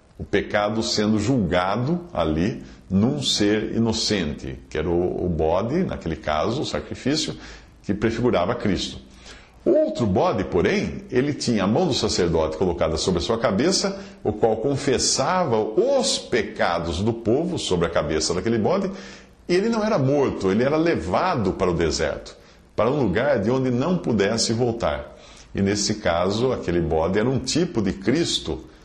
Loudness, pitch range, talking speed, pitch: -22 LUFS, 90-130 Hz, 155 wpm, 110 Hz